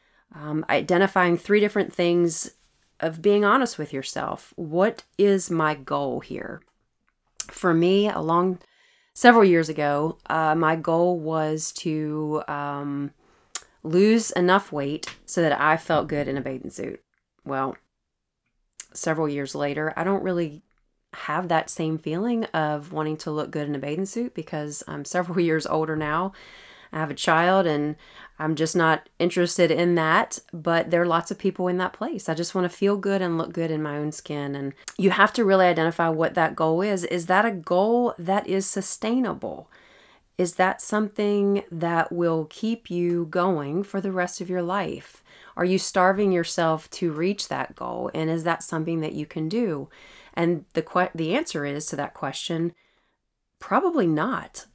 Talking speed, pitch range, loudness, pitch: 170 wpm, 155-190 Hz, -24 LUFS, 170 Hz